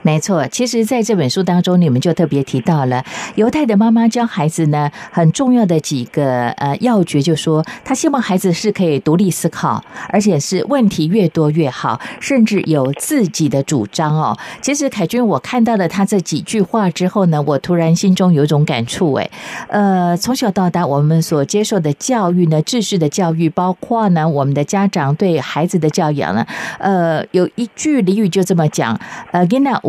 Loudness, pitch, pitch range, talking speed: -15 LUFS, 175 Hz, 155-210 Hz, 290 characters per minute